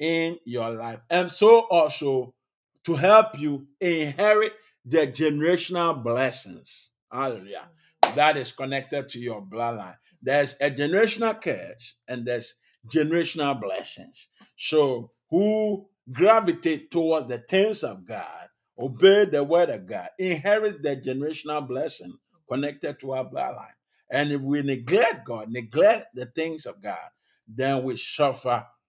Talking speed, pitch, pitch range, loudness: 130 wpm, 145 Hz, 130-170 Hz, -24 LUFS